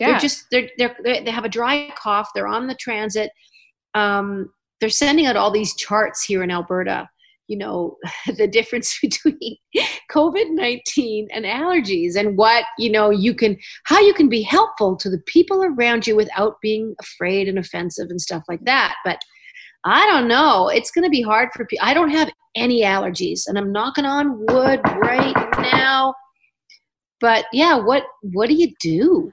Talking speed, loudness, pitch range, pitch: 175 wpm, -18 LUFS, 210-305 Hz, 235 Hz